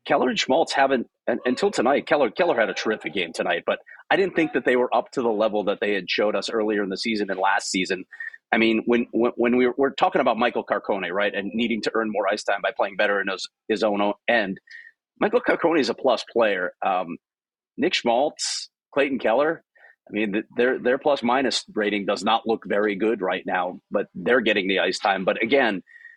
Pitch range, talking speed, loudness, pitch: 110-165 Hz, 220 wpm, -23 LUFS, 120 Hz